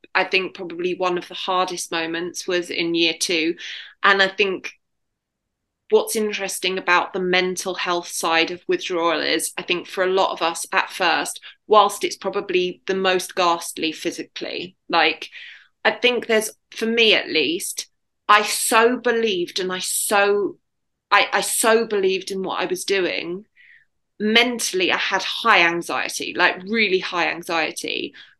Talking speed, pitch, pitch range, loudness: 155 wpm, 190 Hz, 175-225 Hz, -20 LUFS